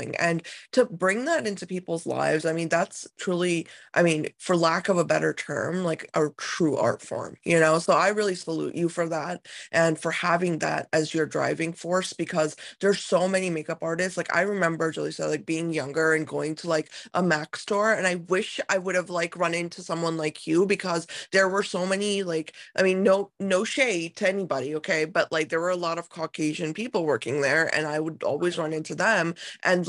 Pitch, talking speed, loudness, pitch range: 170 Hz, 215 wpm, -26 LUFS, 160-185 Hz